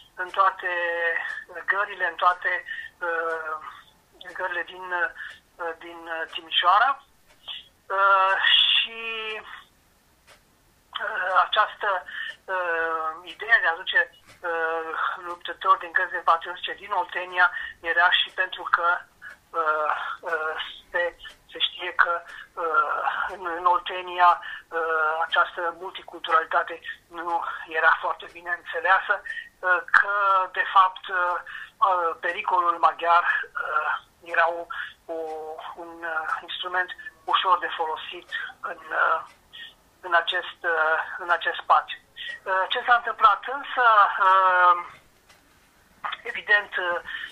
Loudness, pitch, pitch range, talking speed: -24 LUFS, 180 Hz, 170-215 Hz, 105 wpm